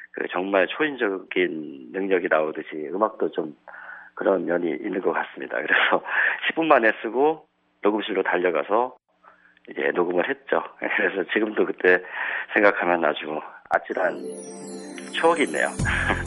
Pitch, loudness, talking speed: 155 Hz, -23 LUFS, 275 characters per minute